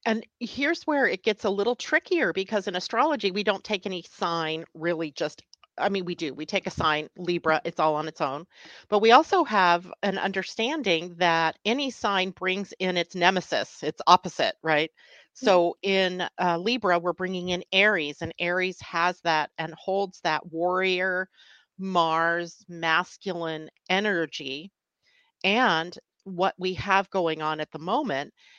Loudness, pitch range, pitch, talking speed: -25 LUFS, 170-205 Hz, 185 Hz, 160 wpm